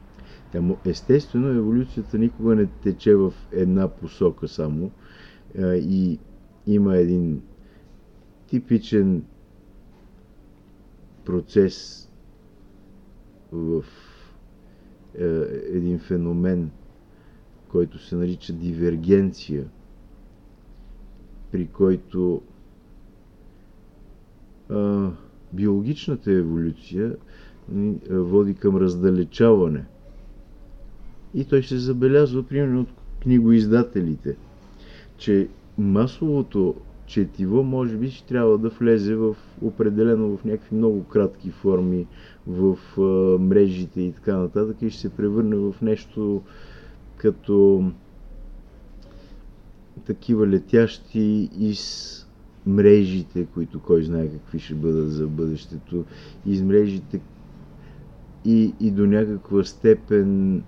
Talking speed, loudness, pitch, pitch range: 80 wpm, -22 LUFS, 100 Hz, 90-110 Hz